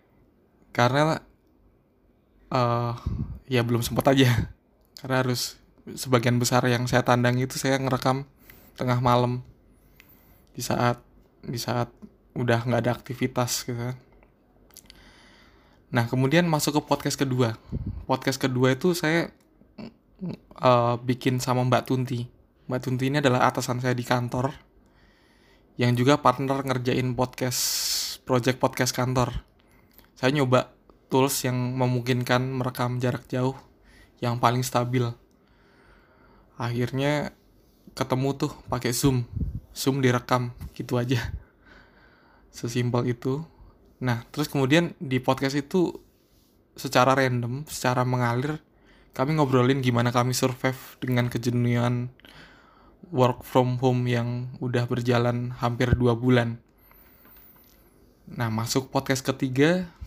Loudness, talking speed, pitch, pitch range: -25 LUFS, 110 wpm, 125 Hz, 120-130 Hz